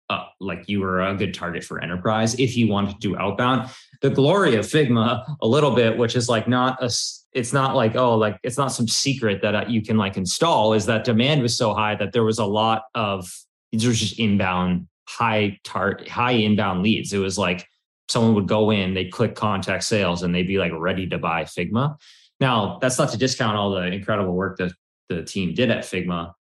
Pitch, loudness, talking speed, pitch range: 110 Hz, -21 LUFS, 220 wpm, 95-120 Hz